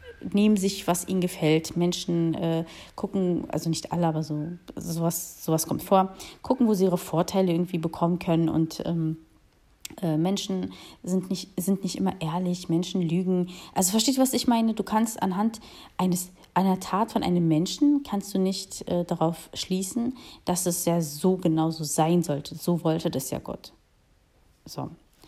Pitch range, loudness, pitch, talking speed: 165-190 Hz, -26 LUFS, 180 Hz, 170 wpm